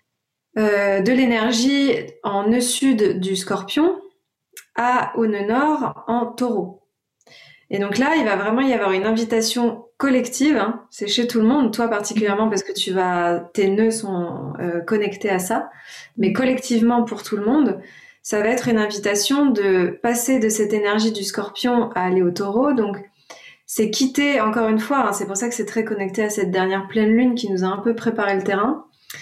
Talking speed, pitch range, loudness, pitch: 190 wpm, 200-240 Hz, -20 LUFS, 220 Hz